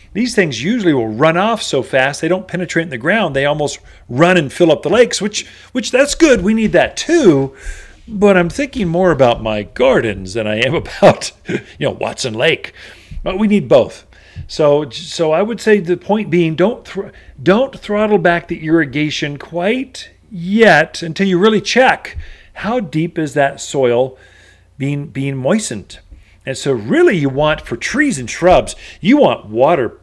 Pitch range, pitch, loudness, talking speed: 140-210 Hz, 175 Hz, -14 LUFS, 180 wpm